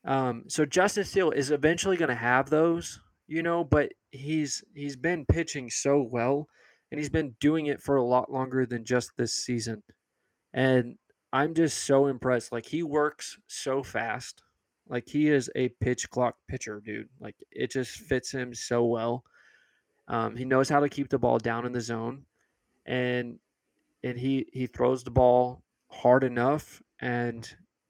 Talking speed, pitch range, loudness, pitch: 170 wpm, 125-145 Hz, -28 LUFS, 130 Hz